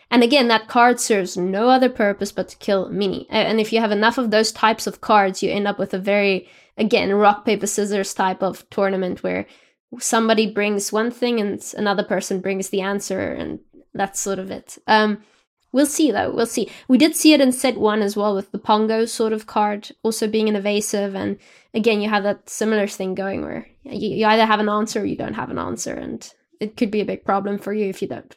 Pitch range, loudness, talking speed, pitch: 200-225 Hz, -20 LUFS, 230 wpm, 210 Hz